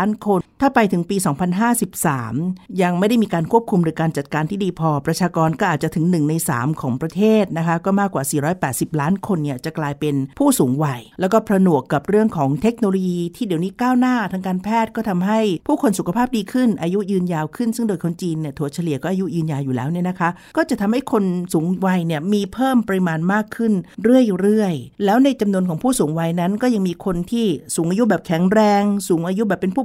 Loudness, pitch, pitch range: -19 LUFS, 185 Hz, 165-215 Hz